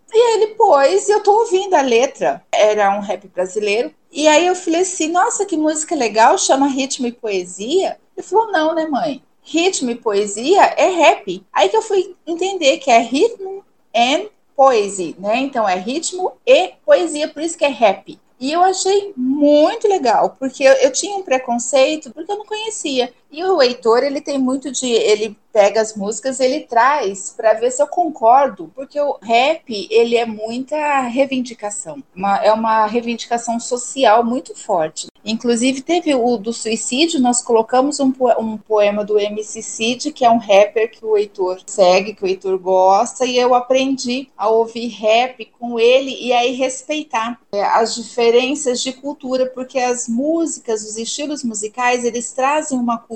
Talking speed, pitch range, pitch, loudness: 175 wpm, 225-305 Hz, 255 Hz, -16 LUFS